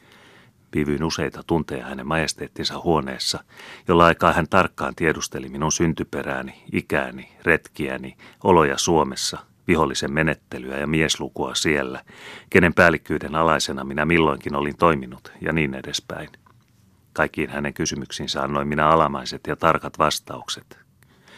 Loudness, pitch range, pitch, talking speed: -22 LUFS, 70-80 Hz, 75 Hz, 115 wpm